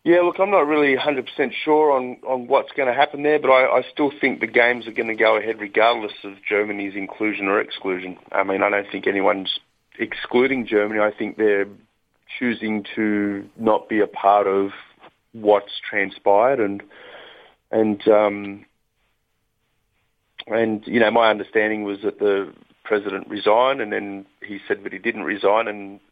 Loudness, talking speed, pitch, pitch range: -20 LUFS, 170 wpm, 105 Hz, 100-120 Hz